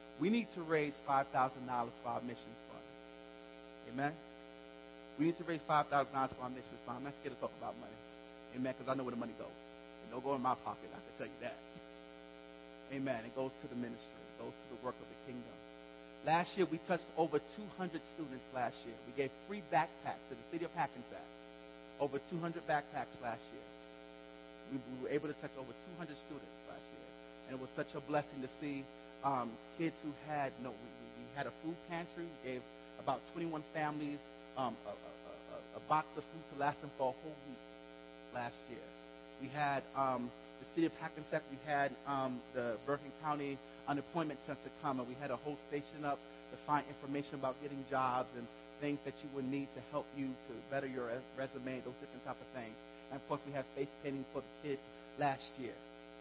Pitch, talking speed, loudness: 130 Hz, 205 wpm, -42 LUFS